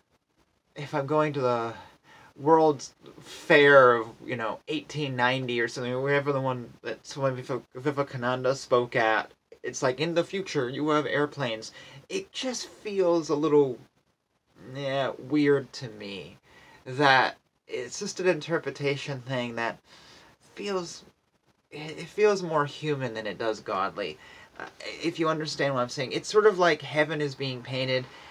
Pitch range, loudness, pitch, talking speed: 130-160 Hz, -27 LUFS, 145 Hz, 145 wpm